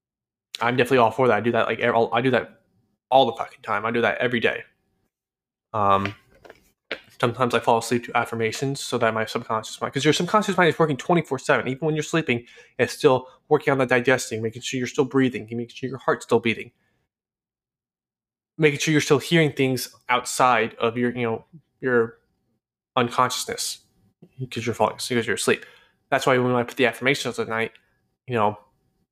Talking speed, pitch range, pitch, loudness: 195 wpm, 115-135 Hz, 125 Hz, -23 LUFS